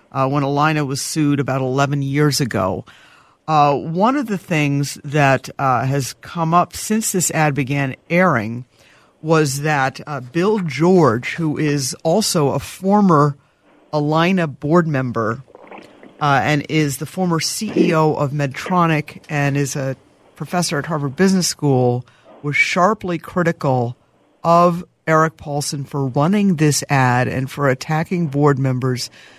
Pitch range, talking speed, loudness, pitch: 135-170 Hz, 140 wpm, -18 LUFS, 150 Hz